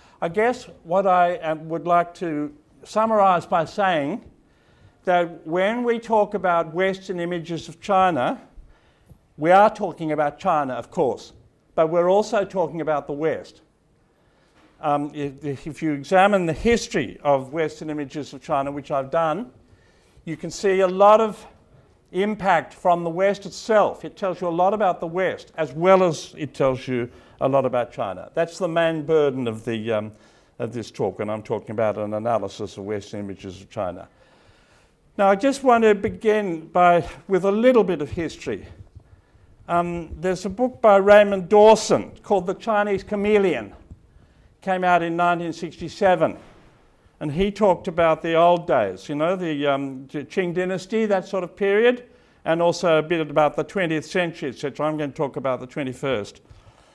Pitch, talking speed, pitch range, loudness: 170 Hz, 170 wpm, 150-195 Hz, -22 LUFS